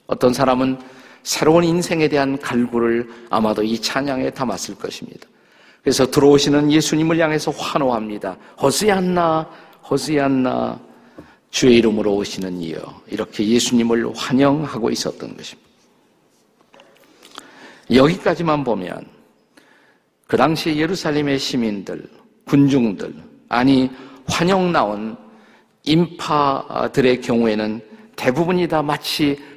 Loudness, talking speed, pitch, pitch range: -18 LUFS, 260 characters per minute, 135 Hz, 120-155 Hz